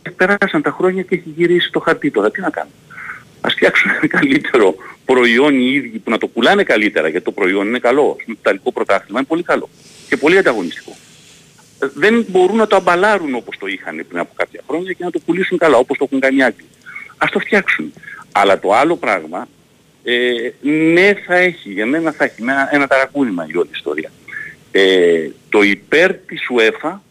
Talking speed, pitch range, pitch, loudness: 190 wpm, 135-220 Hz, 175 Hz, -15 LUFS